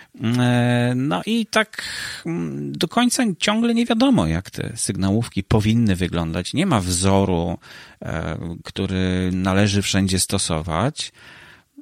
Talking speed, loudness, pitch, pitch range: 100 wpm, -21 LUFS, 110 Hz, 90-145 Hz